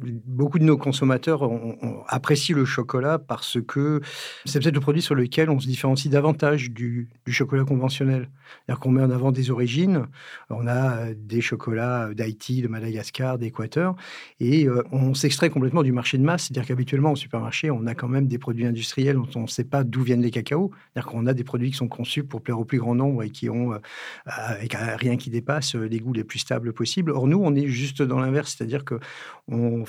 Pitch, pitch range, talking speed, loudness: 130 Hz, 120-140 Hz, 210 wpm, -24 LUFS